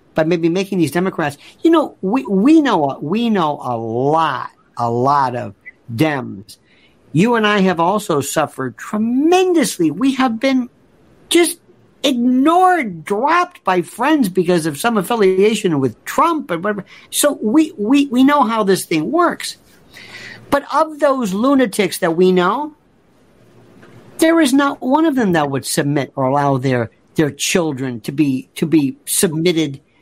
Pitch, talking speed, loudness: 190 Hz, 150 wpm, -16 LUFS